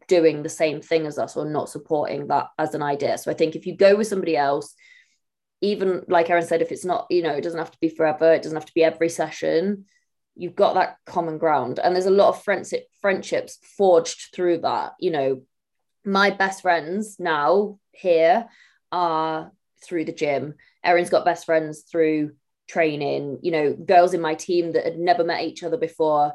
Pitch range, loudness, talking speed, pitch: 160-195 Hz, -22 LUFS, 205 wpm, 170 Hz